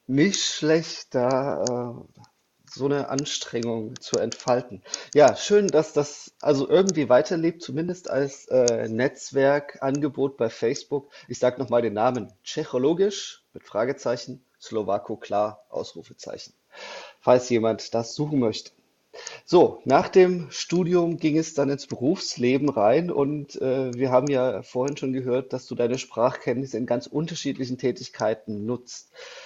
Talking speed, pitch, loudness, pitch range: 130 wpm, 135 Hz, -24 LUFS, 125-155 Hz